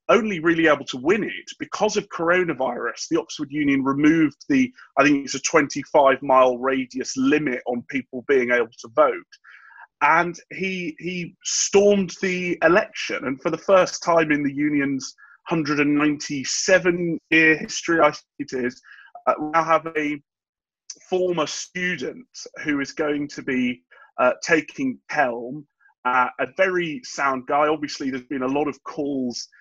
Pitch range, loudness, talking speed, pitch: 140-190 Hz, -21 LUFS, 150 wpm, 155 Hz